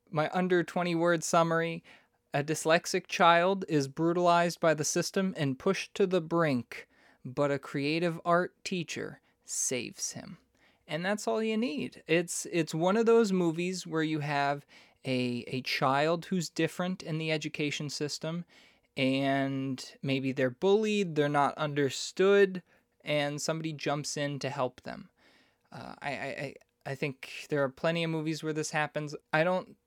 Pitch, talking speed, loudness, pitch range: 160 Hz, 155 wpm, -30 LUFS, 145-175 Hz